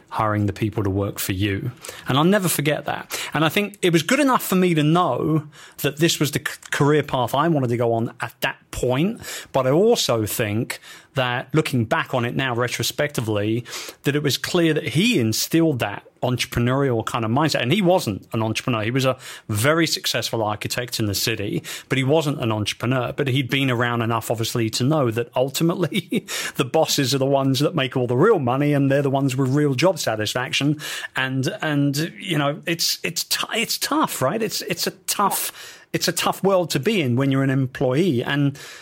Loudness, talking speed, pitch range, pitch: -21 LUFS, 220 wpm, 120-155 Hz, 135 Hz